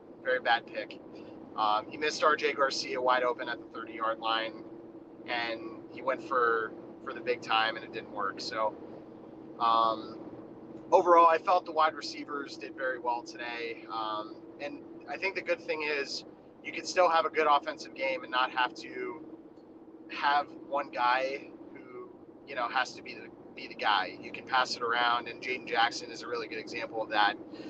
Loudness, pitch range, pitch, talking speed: -30 LUFS, 115-170 Hz, 135 Hz, 185 wpm